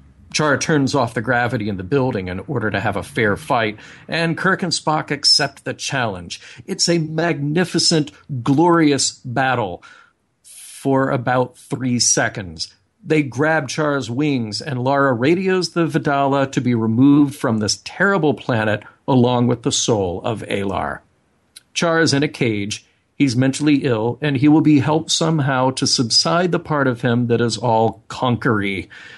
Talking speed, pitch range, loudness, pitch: 160 wpm, 120-155 Hz, -18 LUFS, 135 Hz